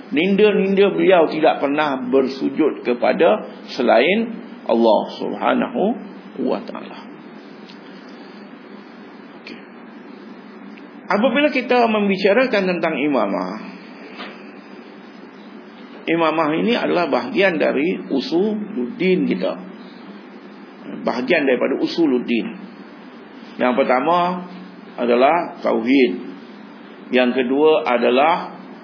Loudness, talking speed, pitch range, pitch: -18 LUFS, 70 wpm, 155-230 Hz, 195 Hz